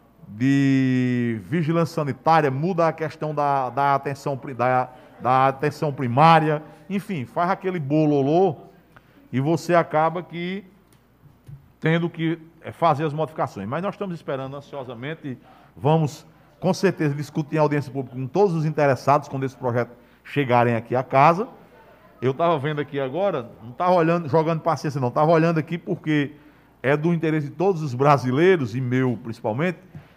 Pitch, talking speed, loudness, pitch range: 150 Hz, 145 wpm, -22 LUFS, 135-165 Hz